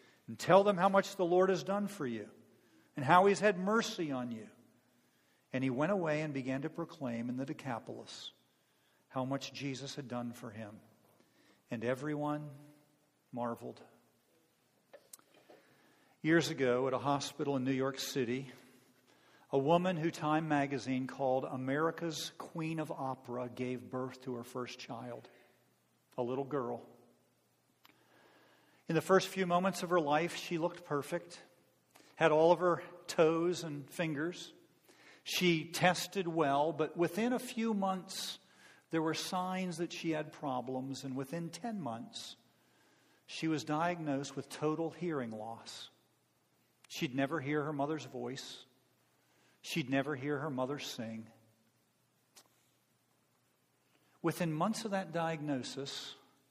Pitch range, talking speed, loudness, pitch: 130-170 Hz, 135 wpm, -35 LUFS, 150 Hz